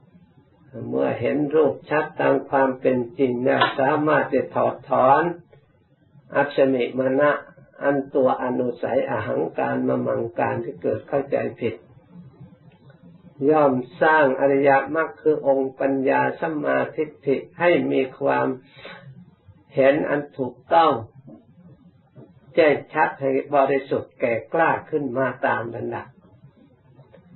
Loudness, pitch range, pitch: -22 LUFS, 130-150 Hz, 140 Hz